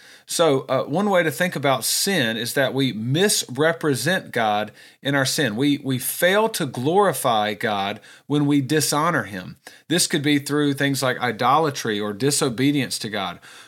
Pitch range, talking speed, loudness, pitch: 130-160 Hz, 160 wpm, -21 LUFS, 140 Hz